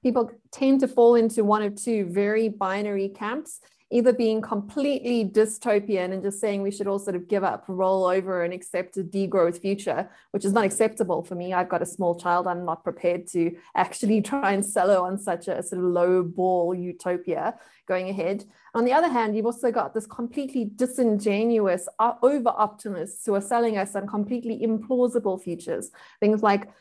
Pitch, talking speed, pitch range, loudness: 205 Hz, 190 wpm, 185-230 Hz, -25 LUFS